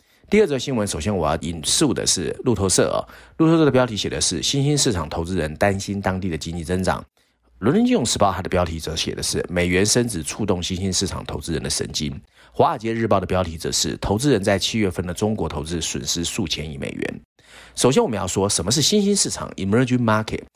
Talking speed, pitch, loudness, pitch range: 375 characters per minute, 95 Hz, -21 LUFS, 85-115 Hz